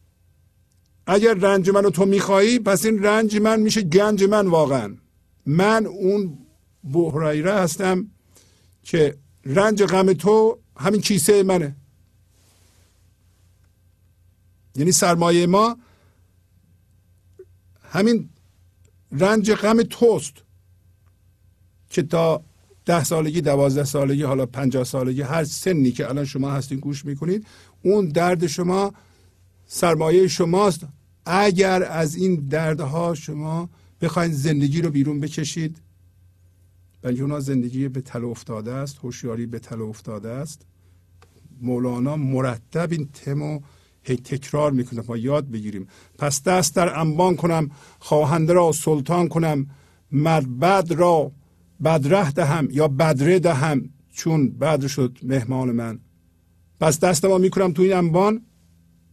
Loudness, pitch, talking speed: -20 LUFS, 145 Hz, 115 wpm